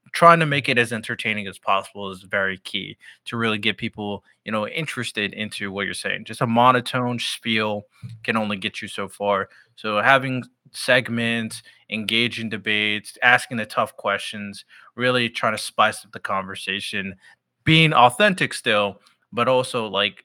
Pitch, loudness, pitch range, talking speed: 115 Hz, -21 LUFS, 105-125 Hz, 160 wpm